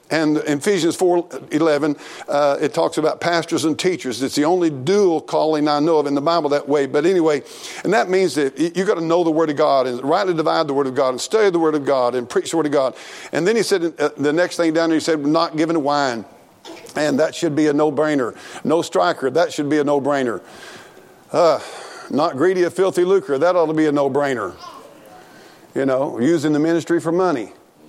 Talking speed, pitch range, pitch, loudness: 225 wpm, 145-170 Hz, 155 Hz, -18 LUFS